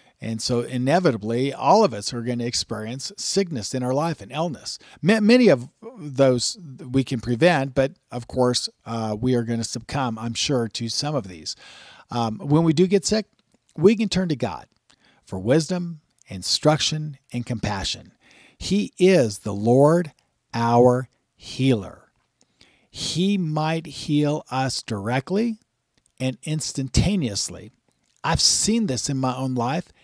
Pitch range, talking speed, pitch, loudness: 120-160 Hz, 145 wpm, 130 Hz, -22 LUFS